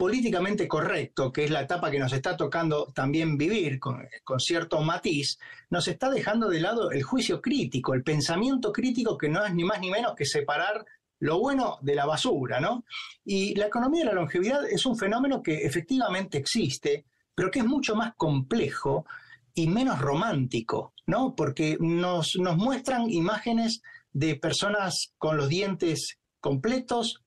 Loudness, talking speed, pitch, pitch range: -27 LUFS, 165 wpm, 180 Hz, 150-235 Hz